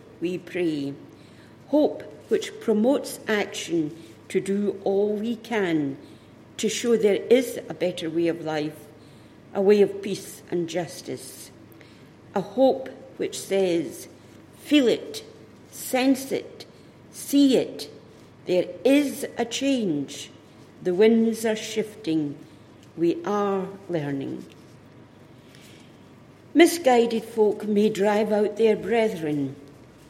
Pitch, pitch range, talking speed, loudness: 200 Hz, 165-230 Hz, 110 wpm, -24 LUFS